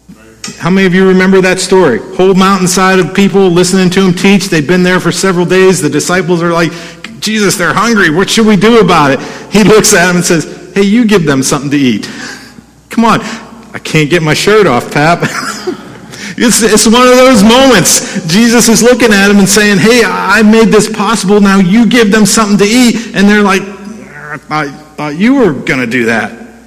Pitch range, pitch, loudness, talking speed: 180-220 Hz, 195 Hz, -7 LUFS, 205 wpm